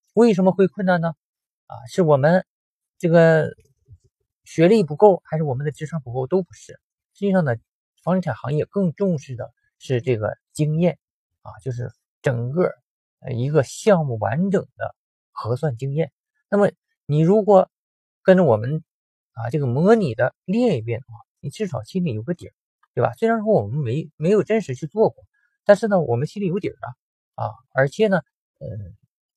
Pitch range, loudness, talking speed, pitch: 130-195 Hz, -21 LUFS, 255 characters per minute, 160 Hz